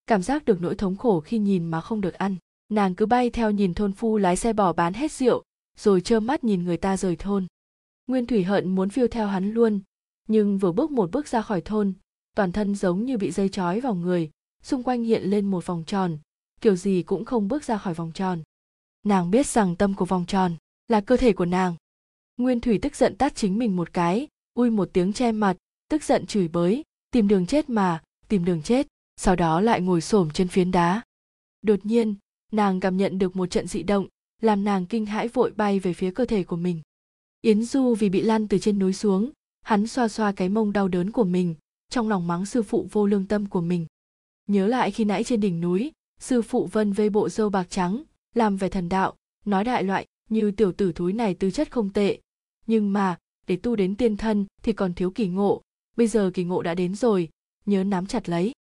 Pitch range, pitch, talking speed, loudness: 185-225 Hz, 205 Hz, 230 wpm, -24 LUFS